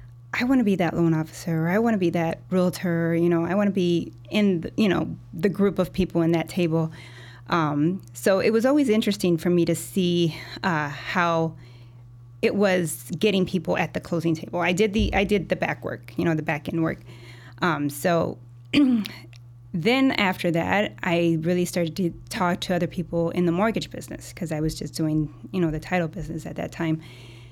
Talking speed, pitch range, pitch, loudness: 205 wpm, 150-185 Hz, 170 Hz, -24 LUFS